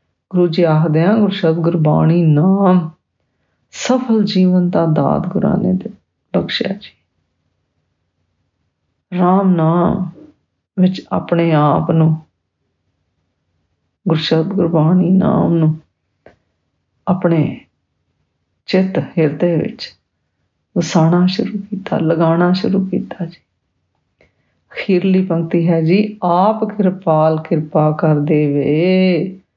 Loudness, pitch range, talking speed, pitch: -15 LUFS, 160-185 Hz, 100 wpm, 170 Hz